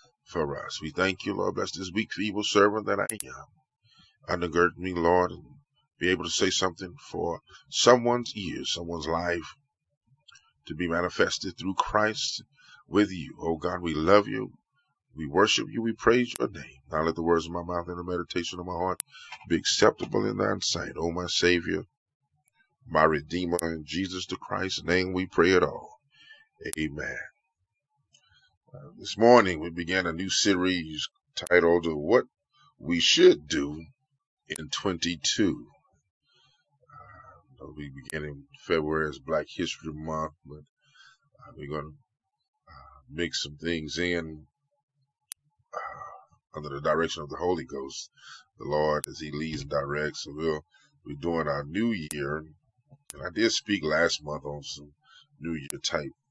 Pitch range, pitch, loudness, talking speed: 80-115 Hz, 90 Hz, -27 LUFS, 155 wpm